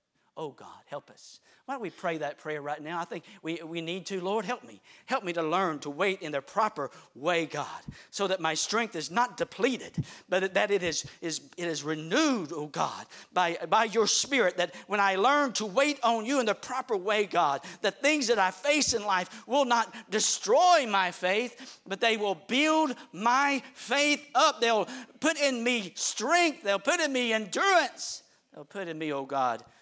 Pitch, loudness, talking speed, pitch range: 205 Hz, -28 LUFS, 205 wpm, 170-250 Hz